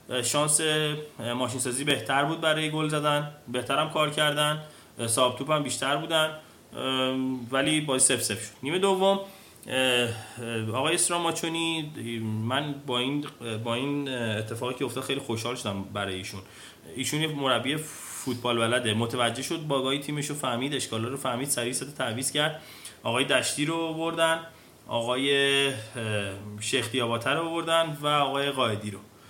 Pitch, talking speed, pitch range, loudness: 135 Hz, 135 wpm, 120-150 Hz, -27 LUFS